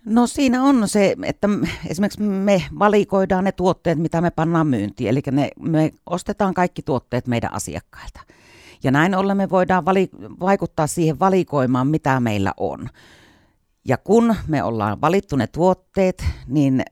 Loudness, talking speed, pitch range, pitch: -20 LUFS, 145 wpm, 130-195 Hz, 165 Hz